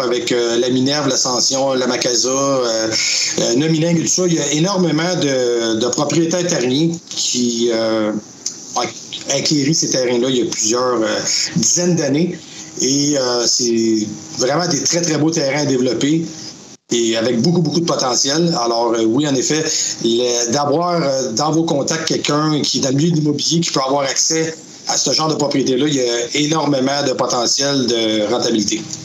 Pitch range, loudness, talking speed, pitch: 120-160 Hz, -16 LUFS, 180 wpm, 140 Hz